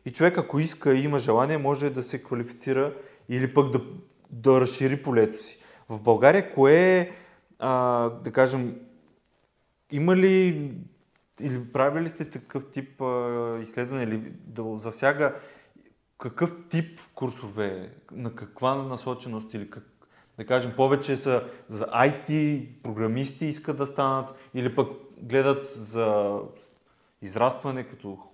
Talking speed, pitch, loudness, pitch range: 130 wpm, 130 Hz, -25 LUFS, 120-140 Hz